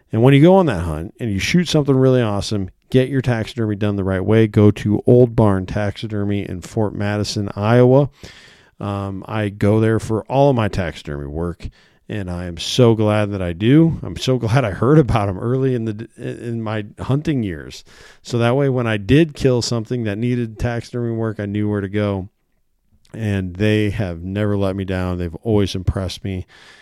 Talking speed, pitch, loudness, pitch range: 200 wpm, 105 Hz, -18 LUFS, 100-120 Hz